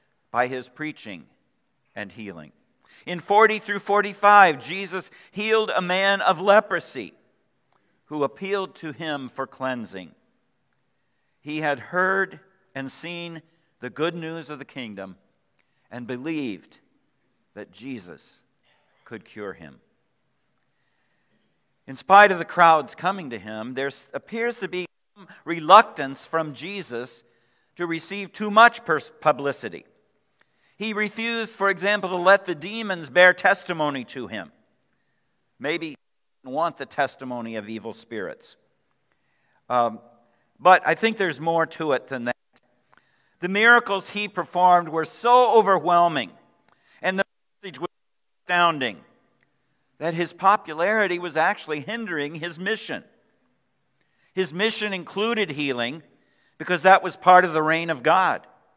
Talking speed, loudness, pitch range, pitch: 130 wpm, -22 LUFS, 140-195 Hz, 170 Hz